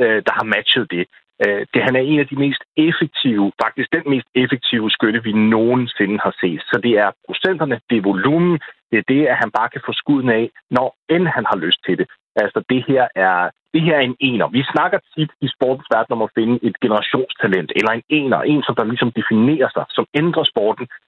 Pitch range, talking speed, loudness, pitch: 110-140 Hz, 220 wpm, -17 LUFS, 125 Hz